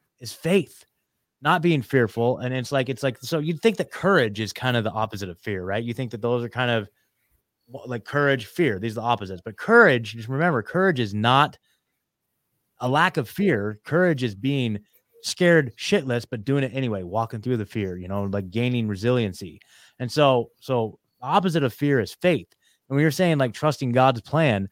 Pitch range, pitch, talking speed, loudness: 110-145 Hz, 125 Hz, 200 wpm, -23 LUFS